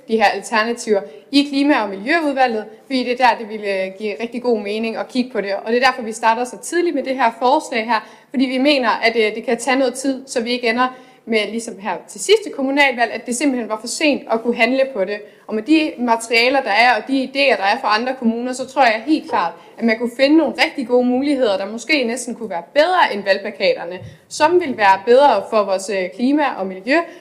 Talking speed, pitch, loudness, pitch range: 240 wpm, 240 Hz, -17 LUFS, 220-270 Hz